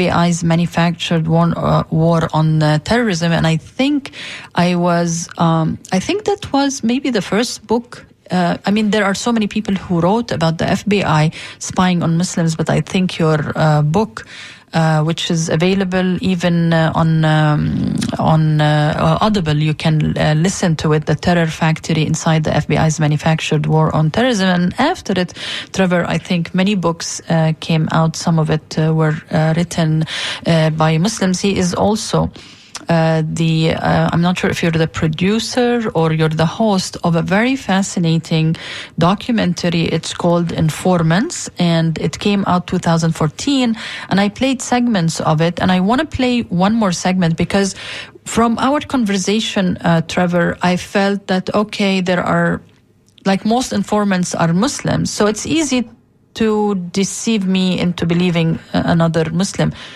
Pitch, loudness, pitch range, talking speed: 175 Hz, -16 LUFS, 160-200 Hz, 160 wpm